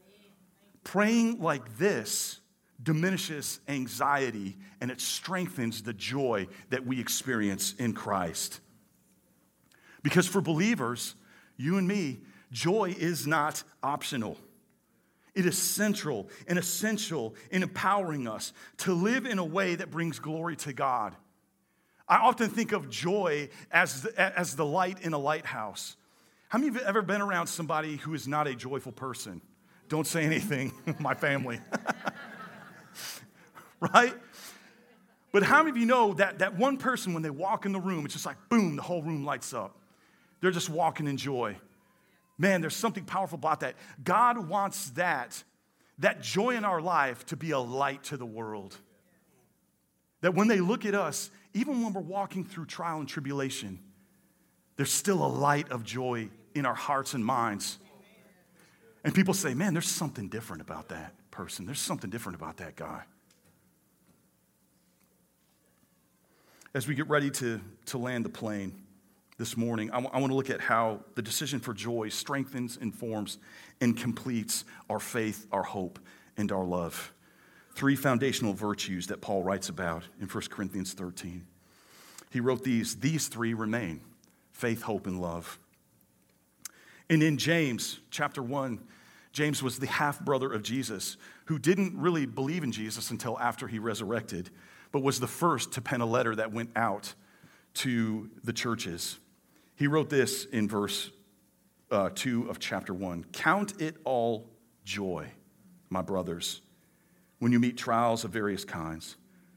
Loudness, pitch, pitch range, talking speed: -31 LUFS, 140 Hz, 115-180 Hz, 155 wpm